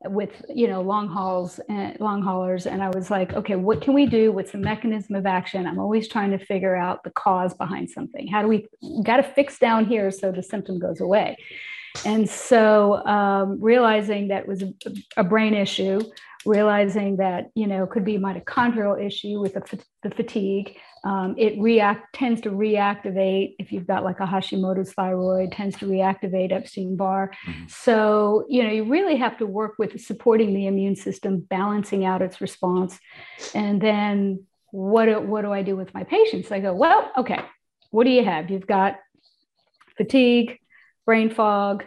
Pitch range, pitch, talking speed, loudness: 195-220 Hz, 205 Hz, 185 wpm, -22 LUFS